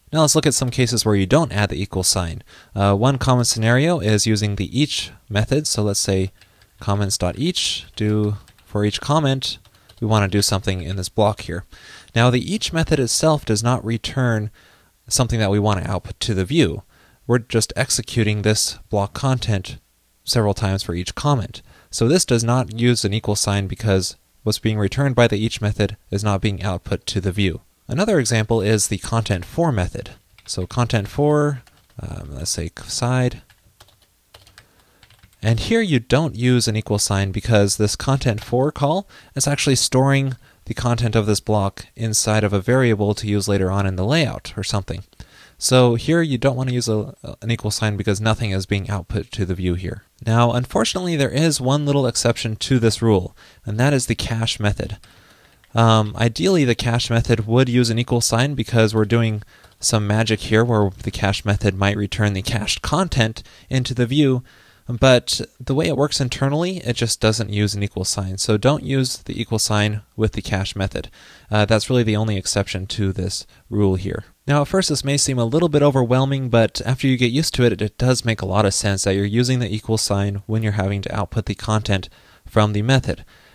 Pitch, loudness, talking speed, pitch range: 110 Hz, -19 LUFS, 195 wpm, 100-125 Hz